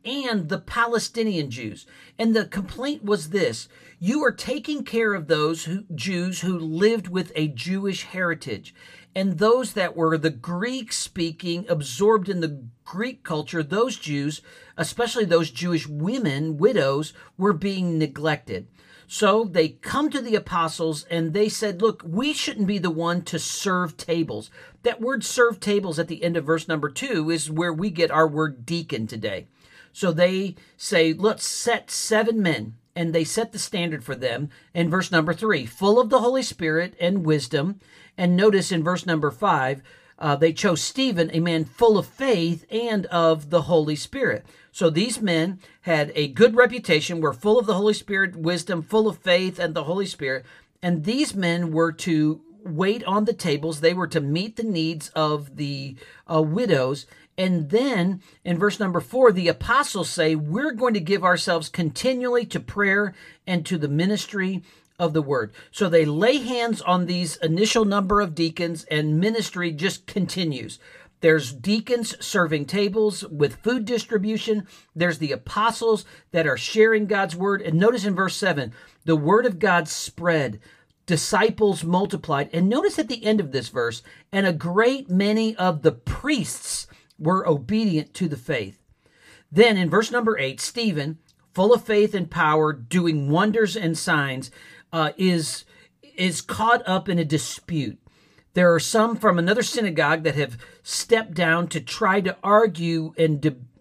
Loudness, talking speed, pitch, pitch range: -23 LUFS, 170 wpm, 175 Hz, 160-210 Hz